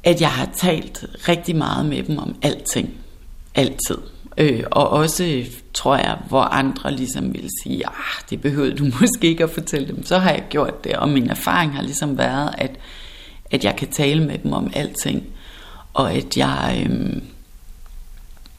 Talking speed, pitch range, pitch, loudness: 175 wpm, 110-165 Hz, 145 Hz, -20 LUFS